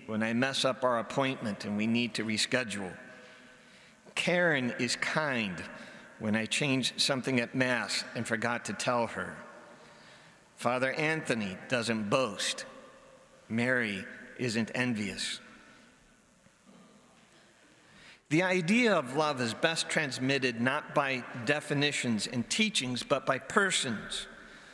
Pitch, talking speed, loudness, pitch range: 125 Hz, 115 wpm, -30 LUFS, 115-145 Hz